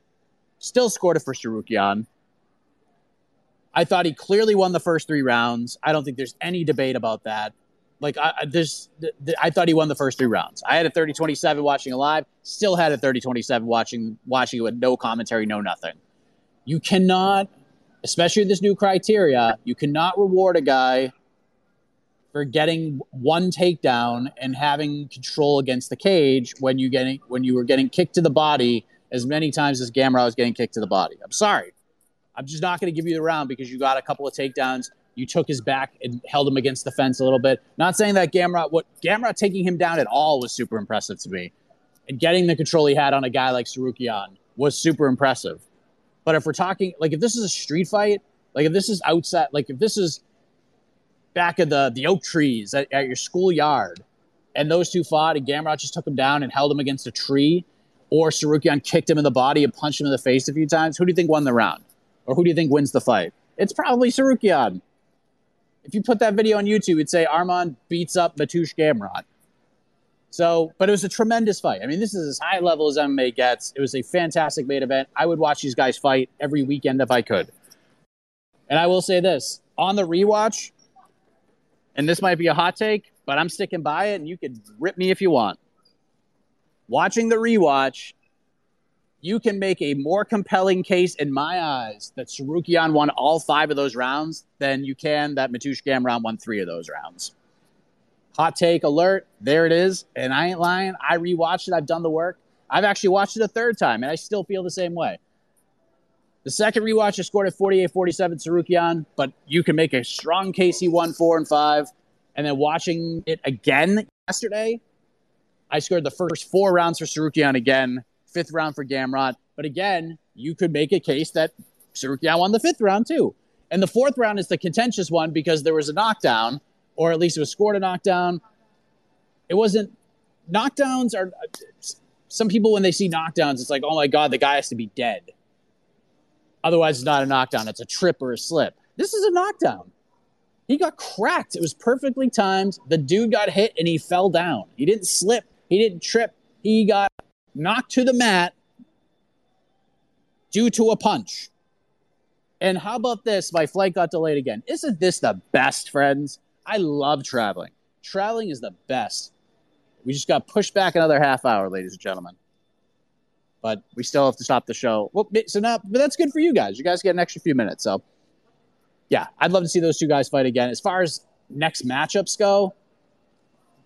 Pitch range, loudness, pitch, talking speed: 140-190 Hz, -21 LUFS, 165 Hz, 205 wpm